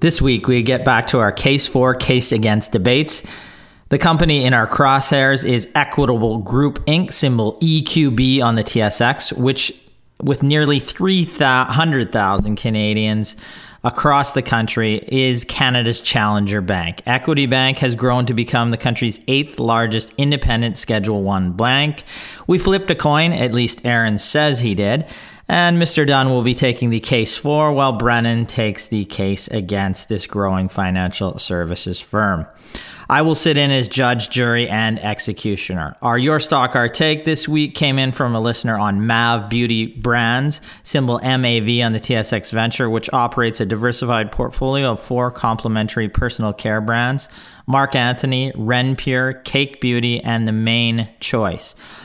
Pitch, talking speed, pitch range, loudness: 120 Hz, 155 wpm, 110-135 Hz, -17 LUFS